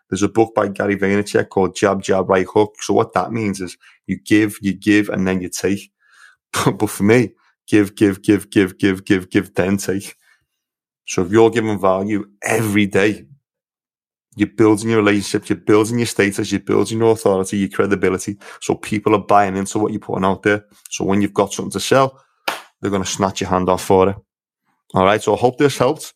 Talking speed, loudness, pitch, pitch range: 205 wpm, -17 LUFS, 100 Hz, 95-105 Hz